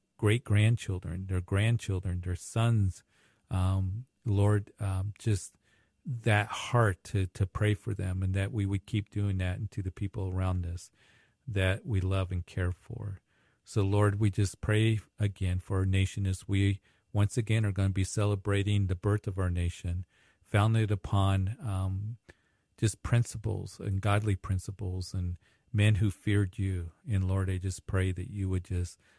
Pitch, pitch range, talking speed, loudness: 100 Hz, 95-105 Hz, 165 wpm, -31 LUFS